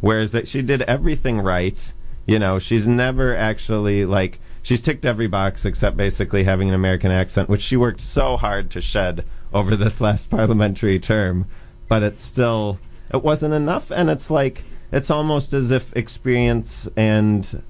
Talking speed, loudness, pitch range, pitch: 165 wpm, -20 LUFS, 100-120 Hz, 110 Hz